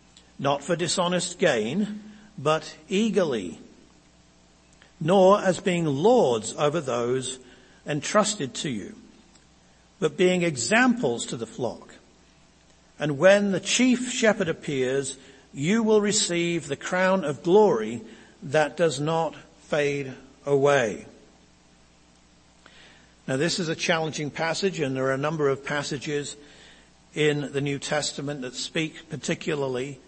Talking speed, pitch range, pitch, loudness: 120 wpm, 135-180 Hz, 150 Hz, -24 LUFS